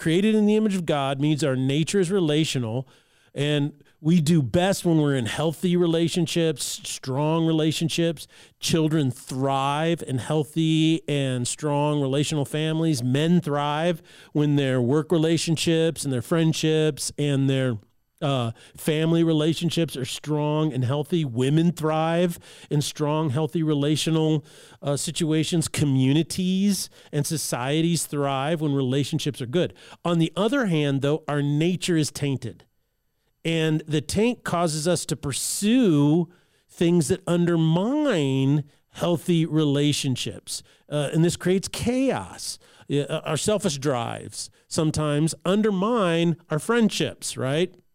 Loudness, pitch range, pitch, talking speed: -24 LUFS, 145-170 Hz, 155 Hz, 125 wpm